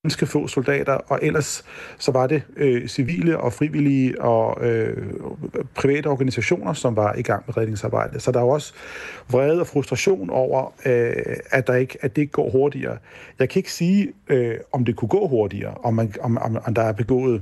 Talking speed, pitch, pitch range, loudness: 195 wpm, 130 Hz, 120-145 Hz, -22 LUFS